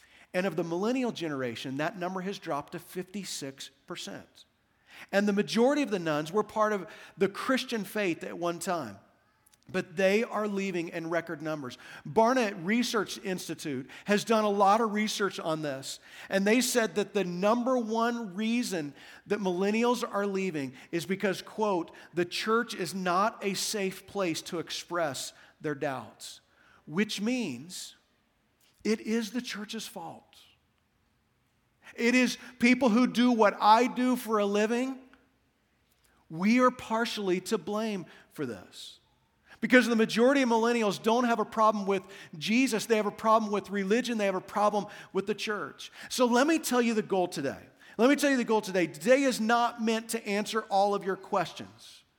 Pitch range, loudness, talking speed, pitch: 180-230 Hz, -29 LUFS, 165 wpm, 205 Hz